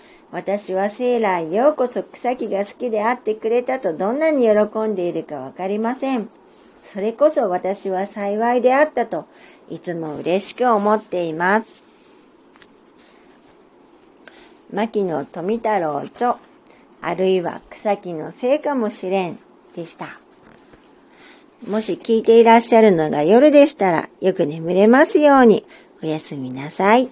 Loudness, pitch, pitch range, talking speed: -18 LUFS, 215 Hz, 185-250 Hz, 265 characters per minute